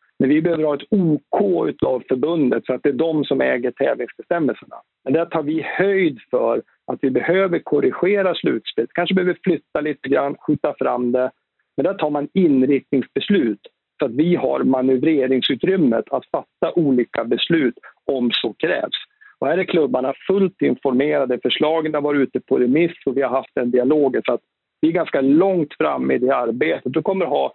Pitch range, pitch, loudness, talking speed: 130-170 Hz, 150 Hz, -19 LUFS, 180 wpm